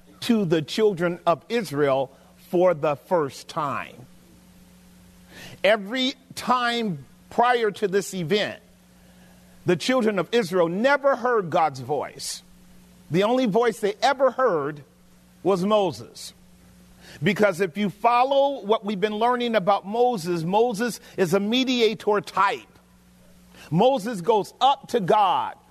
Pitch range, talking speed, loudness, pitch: 145-240 Hz, 120 wpm, -23 LUFS, 200 Hz